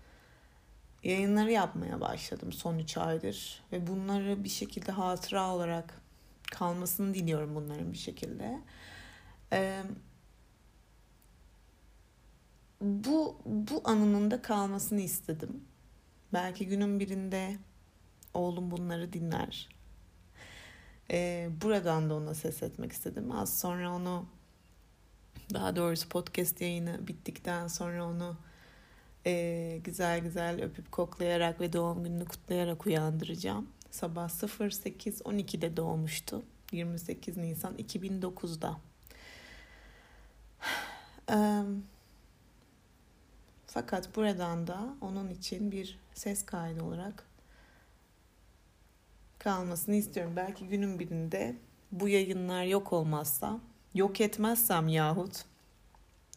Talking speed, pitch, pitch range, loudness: 90 wpm, 175 Hz, 160-195 Hz, -35 LUFS